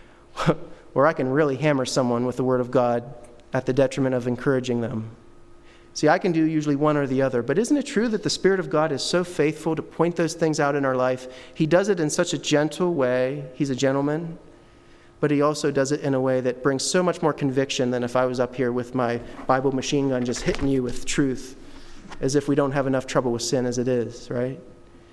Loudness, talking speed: -23 LUFS, 240 wpm